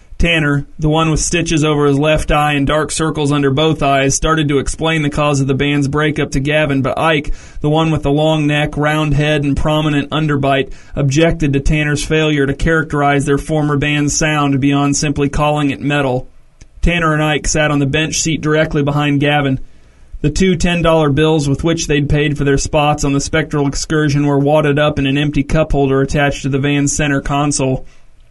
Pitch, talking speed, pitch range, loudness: 145 Hz, 200 wpm, 140-155 Hz, -14 LUFS